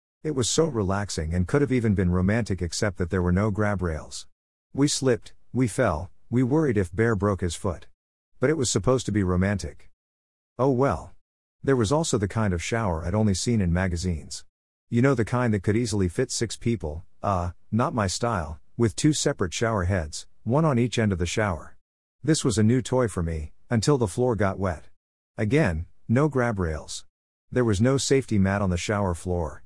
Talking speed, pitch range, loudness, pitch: 205 wpm, 90-120 Hz, -25 LUFS, 100 Hz